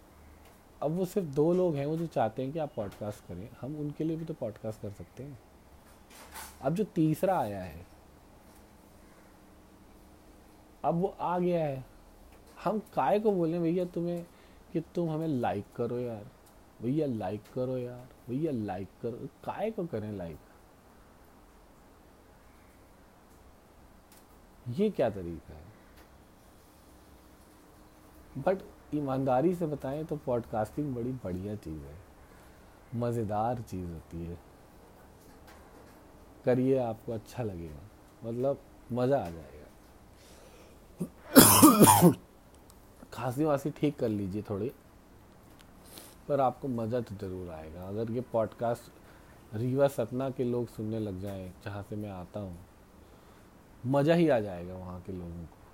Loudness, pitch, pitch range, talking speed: -30 LUFS, 110 Hz, 90-140 Hz, 125 wpm